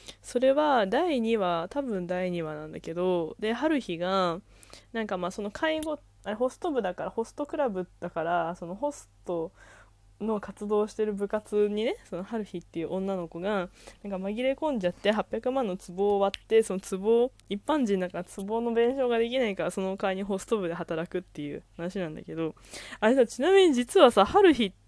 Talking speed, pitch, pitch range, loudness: 350 characters per minute, 200 Hz, 175-235 Hz, -28 LUFS